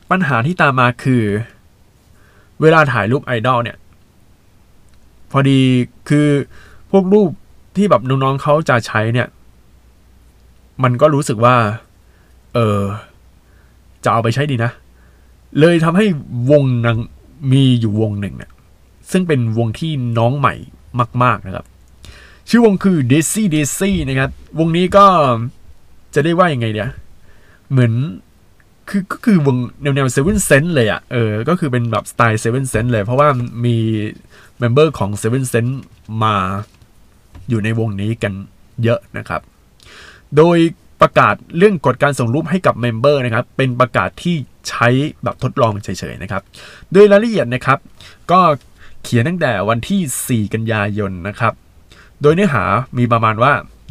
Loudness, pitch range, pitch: -15 LUFS, 105-145 Hz, 120 Hz